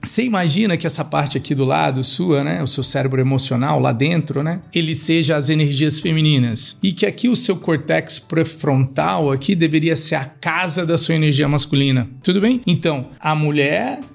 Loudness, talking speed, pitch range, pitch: -18 LUFS, 180 wpm, 140-170 Hz, 155 Hz